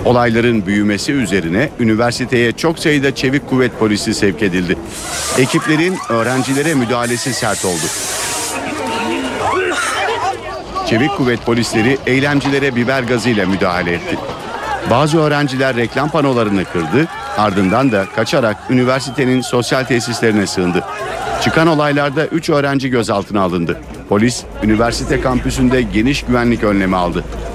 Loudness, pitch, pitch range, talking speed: -15 LUFS, 120 Hz, 105-135 Hz, 110 wpm